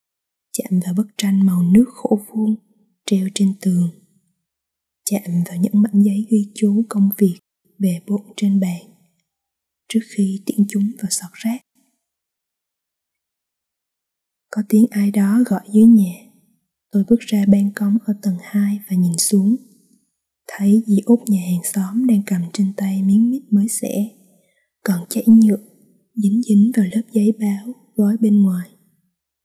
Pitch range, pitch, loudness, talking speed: 185-215 Hz, 205 Hz, -18 LUFS, 155 wpm